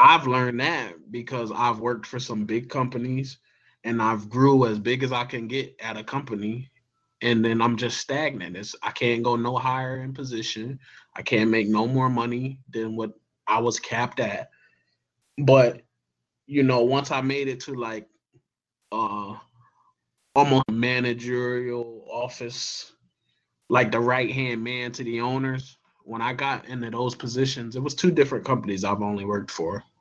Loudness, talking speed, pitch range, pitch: -25 LUFS, 165 wpm, 115-130 Hz, 120 Hz